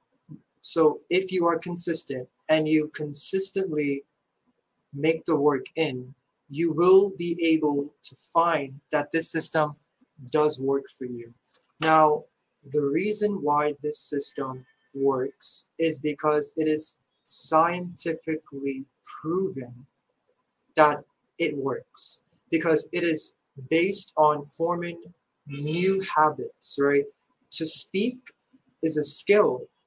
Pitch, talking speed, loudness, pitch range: 155 Hz, 110 wpm, -25 LUFS, 140-170 Hz